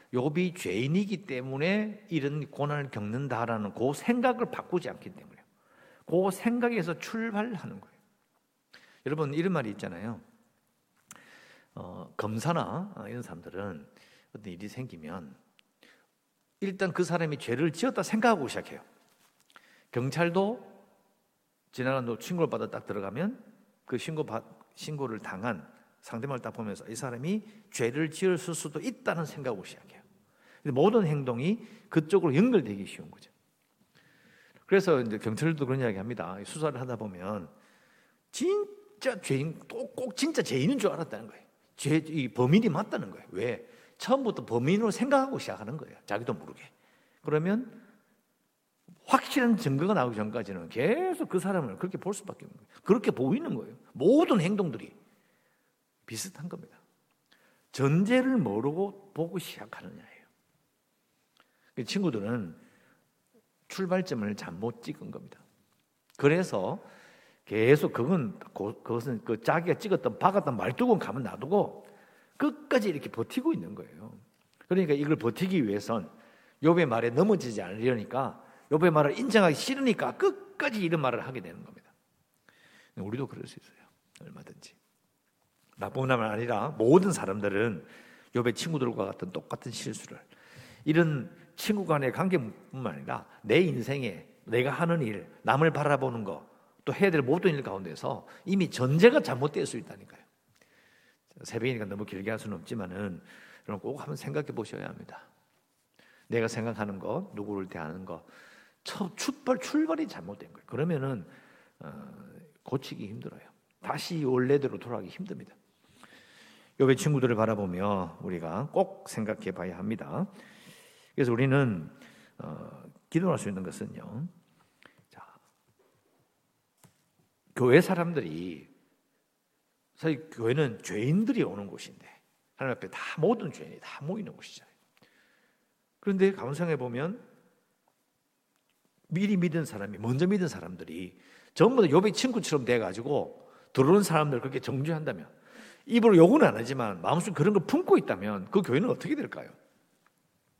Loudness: -29 LUFS